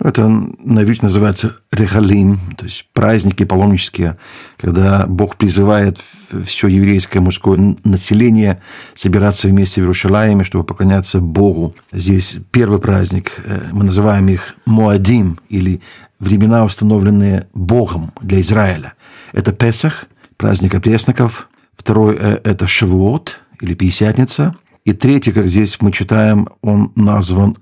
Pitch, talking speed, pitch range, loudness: 100 Hz, 115 wpm, 95-110 Hz, -13 LUFS